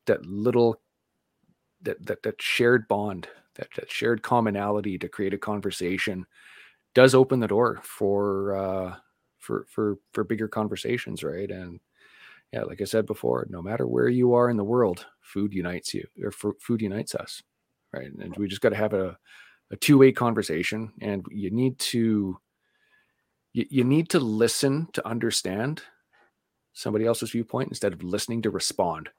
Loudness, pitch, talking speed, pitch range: -25 LUFS, 105 Hz, 160 wpm, 100-120 Hz